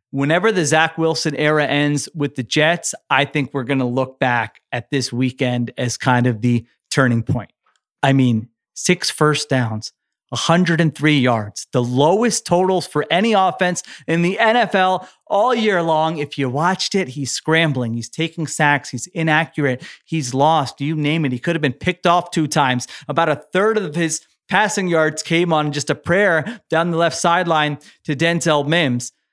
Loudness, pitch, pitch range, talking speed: -18 LUFS, 155 Hz, 135-170 Hz, 180 wpm